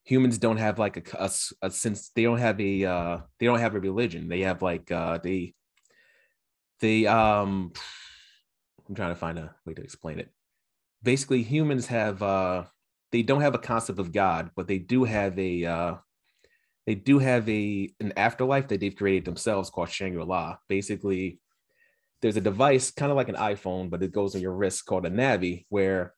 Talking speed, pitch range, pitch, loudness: 195 wpm, 90-115 Hz, 100 Hz, -27 LUFS